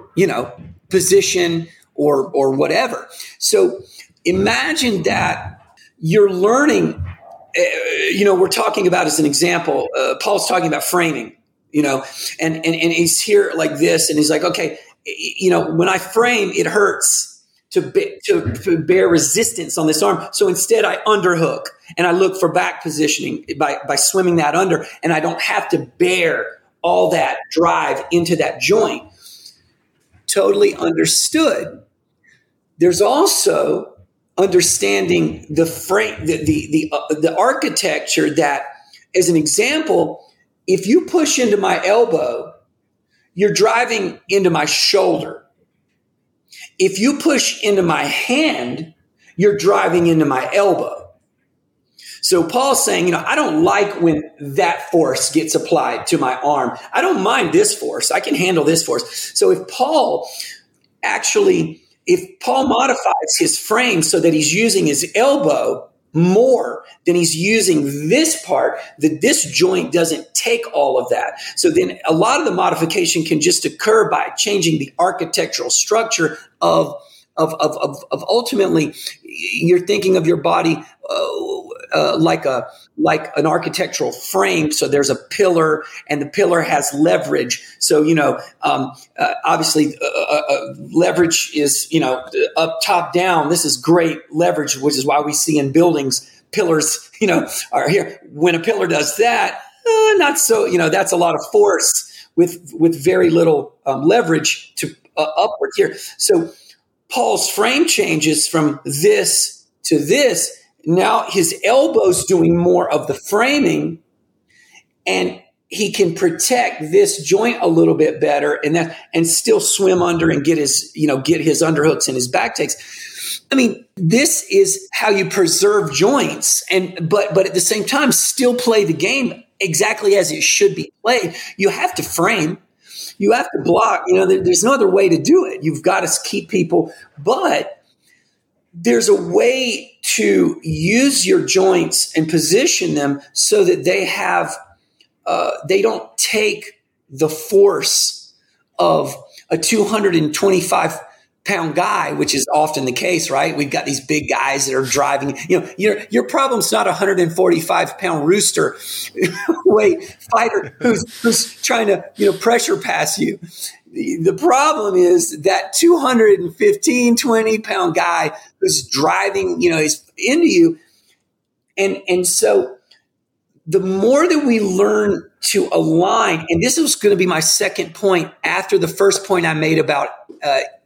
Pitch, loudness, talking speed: 200 Hz, -16 LUFS, 155 wpm